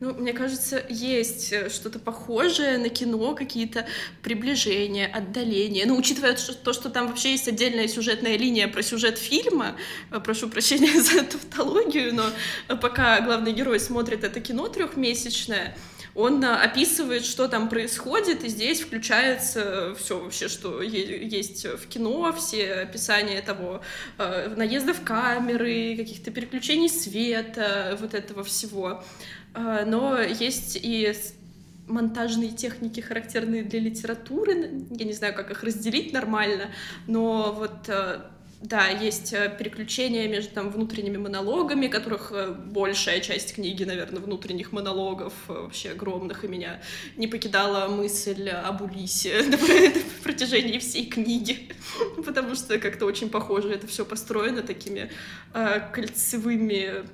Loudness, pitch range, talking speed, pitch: -25 LUFS, 205-245 Hz, 125 wpm, 225 Hz